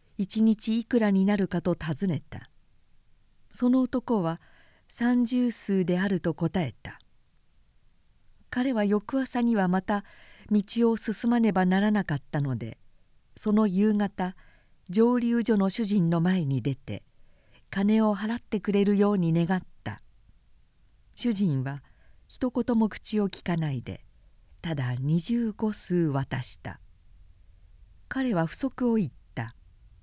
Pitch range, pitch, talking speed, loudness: 140-220 Hz, 190 Hz, 215 characters per minute, -27 LUFS